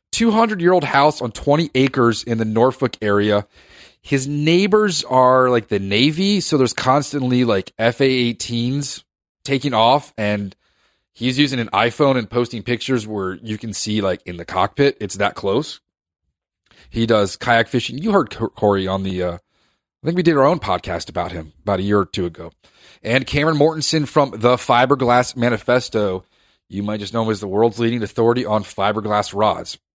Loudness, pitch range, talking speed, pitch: -18 LUFS, 105-135 Hz, 180 wpm, 120 Hz